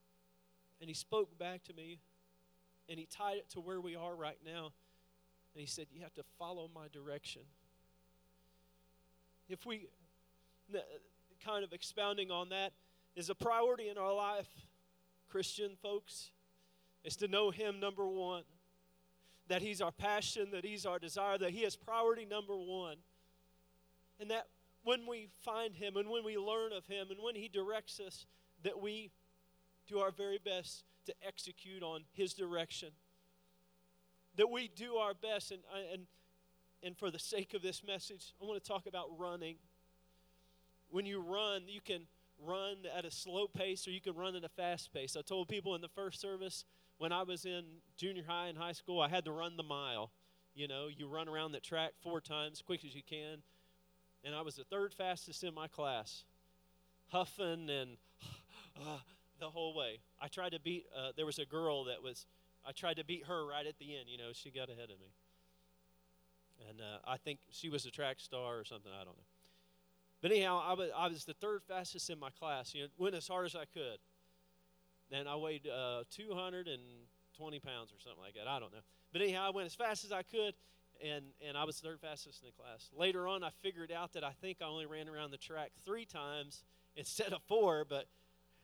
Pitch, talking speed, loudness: 160 Hz, 195 wpm, -42 LUFS